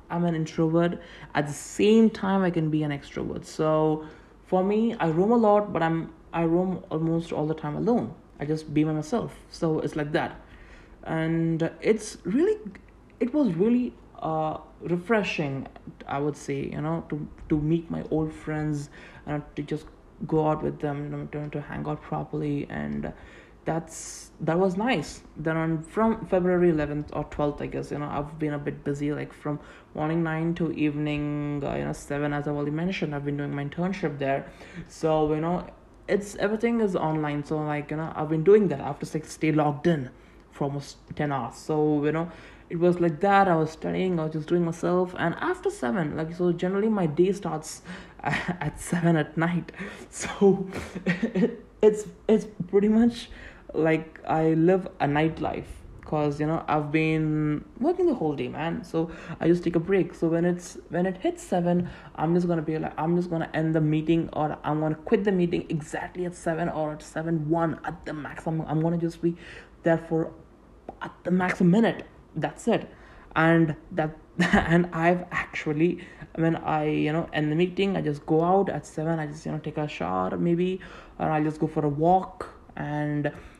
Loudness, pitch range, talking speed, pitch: -26 LUFS, 150-175 Hz, 195 wpm, 160 Hz